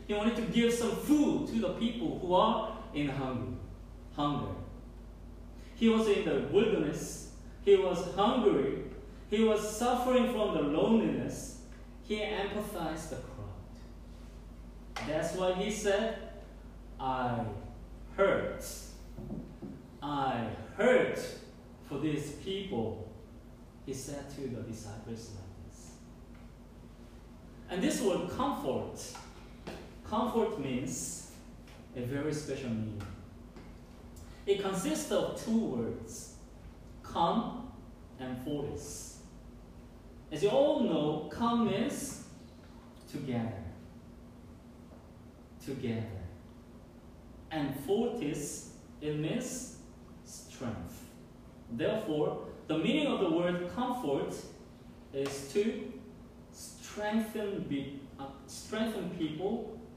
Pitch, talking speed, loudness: 140 Hz, 95 wpm, -33 LUFS